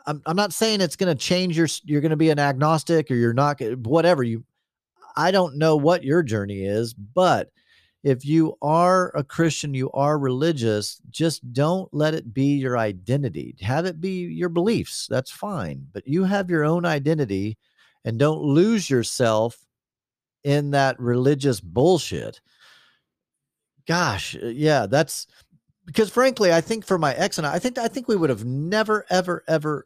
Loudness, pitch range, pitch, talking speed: -22 LUFS, 130-175 Hz, 155 Hz, 175 wpm